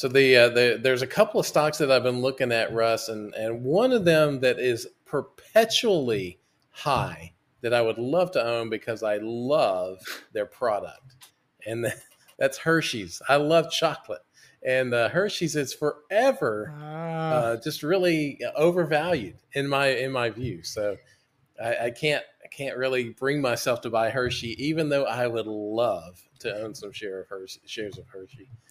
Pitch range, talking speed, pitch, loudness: 115-155 Hz, 170 wpm, 135 Hz, -25 LUFS